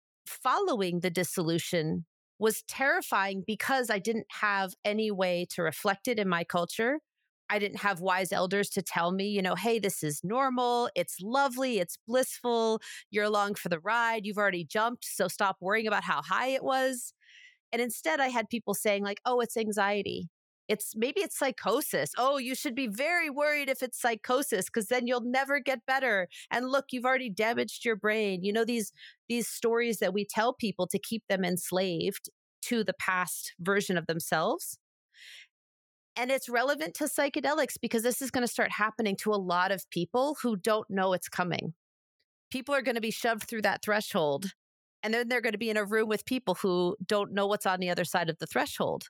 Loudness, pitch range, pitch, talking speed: -30 LUFS, 190-245 Hz, 215 Hz, 195 wpm